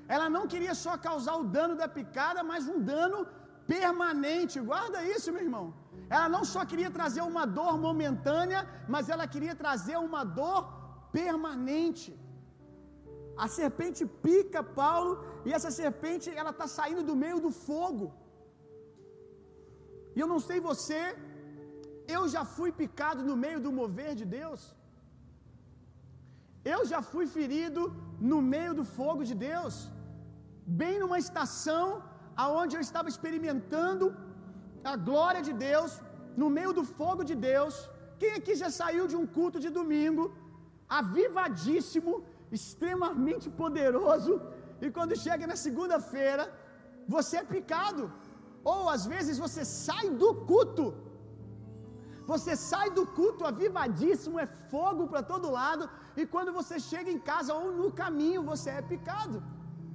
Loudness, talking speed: -32 LUFS, 135 wpm